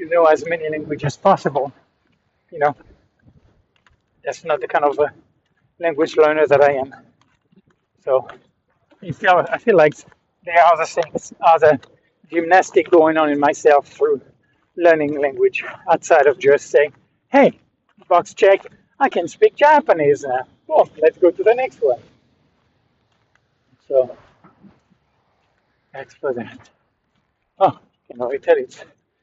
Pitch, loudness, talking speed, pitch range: 160 Hz, -17 LUFS, 140 wpm, 145-195 Hz